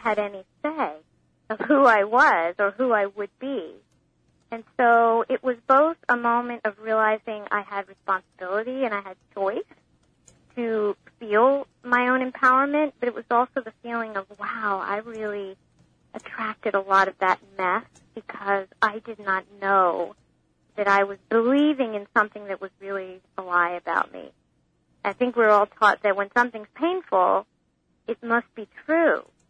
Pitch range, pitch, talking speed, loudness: 195-240 Hz, 215 Hz, 165 wpm, -23 LUFS